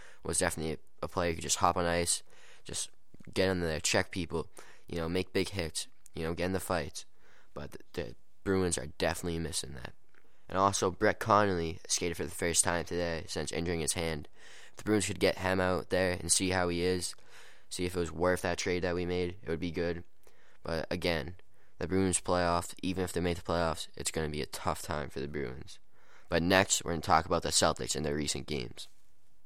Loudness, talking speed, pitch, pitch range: -32 LUFS, 220 wpm, 85 Hz, 80-90 Hz